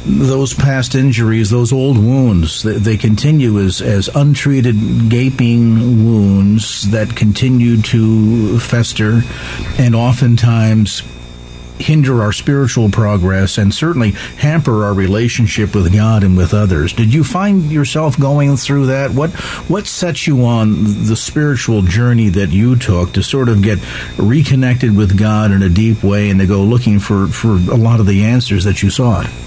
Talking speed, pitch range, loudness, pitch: 155 wpm, 100-130 Hz, -12 LUFS, 115 Hz